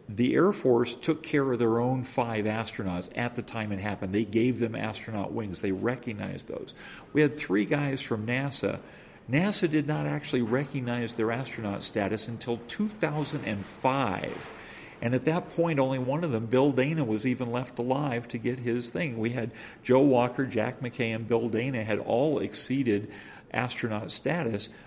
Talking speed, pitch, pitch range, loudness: 175 wpm, 120 Hz, 110-135 Hz, -29 LUFS